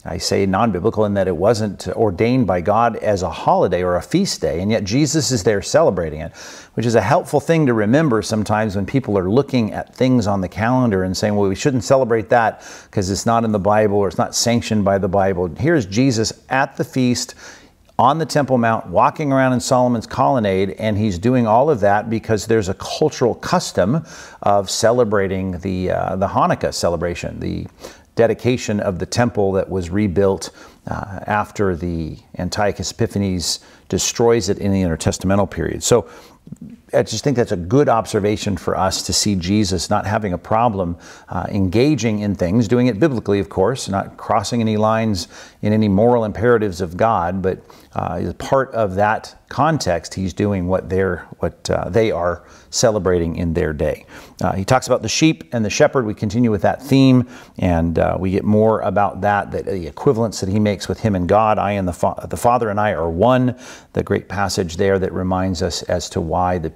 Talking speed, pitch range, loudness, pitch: 195 wpm, 95-120 Hz, -18 LUFS, 105 Hz